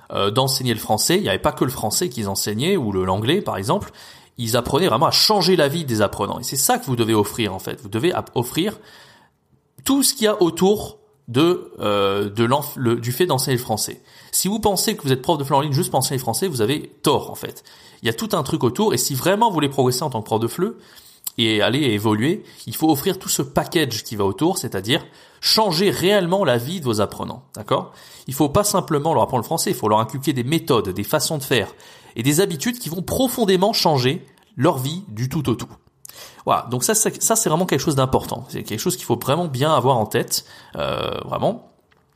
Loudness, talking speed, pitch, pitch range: -20 LUFS, 240 wpm, 145 Hz, 120-185 Hz